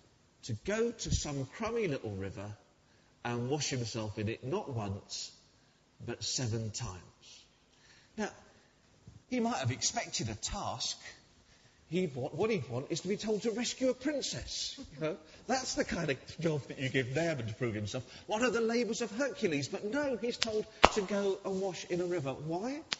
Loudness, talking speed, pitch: -35 LUFS, 180 wpm, 155 Hz